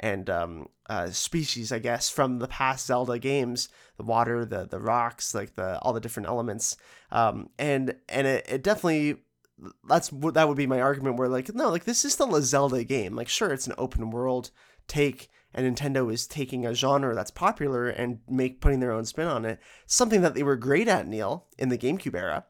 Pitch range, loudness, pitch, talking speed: 120-140 Hz, -27 LUFS, 130 Hz, 200 wpm